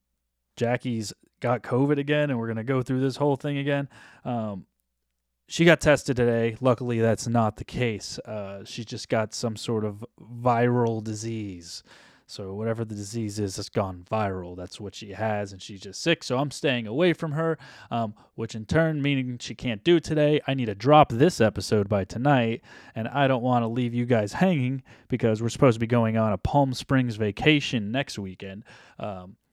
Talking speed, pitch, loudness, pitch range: 195 wpm, 115 Hz, -25 LUFS, 105-135 Hz